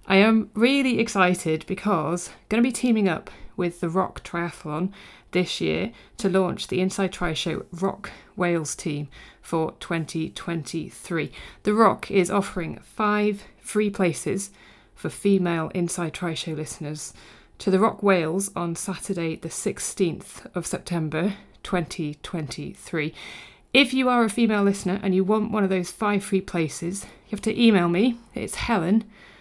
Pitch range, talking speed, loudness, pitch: 170-210 Hz, 150 wpm, -24 LUFS, 185 Hz